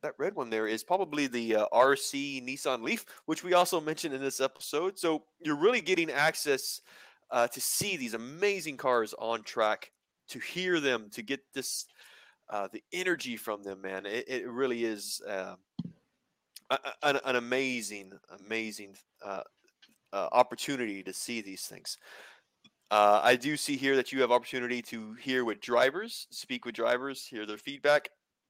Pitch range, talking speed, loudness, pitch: 110-155 Hz, 165 wpm, -31 LUFS, 130 Hz